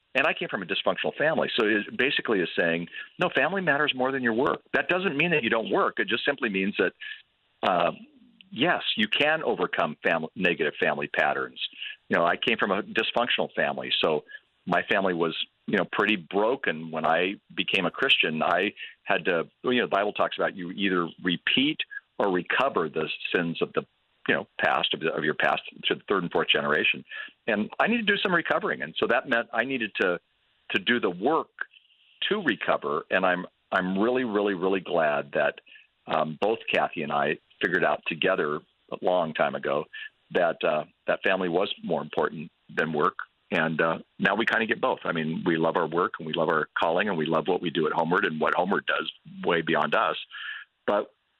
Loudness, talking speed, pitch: -26 LUFS, 205 wpm, 195 Hz